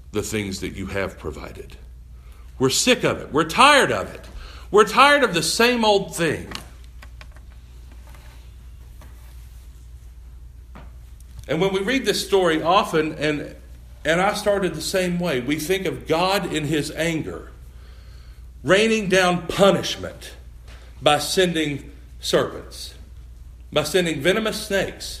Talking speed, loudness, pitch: 125 wpm, -20 LUFS, 95 Hz